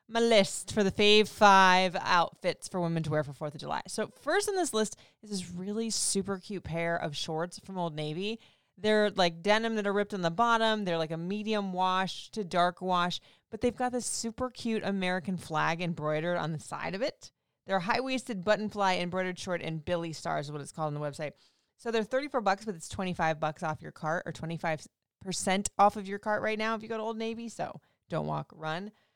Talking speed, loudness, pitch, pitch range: 230 wpm, -30 LUFS, 190 Hz, 165-215 Hz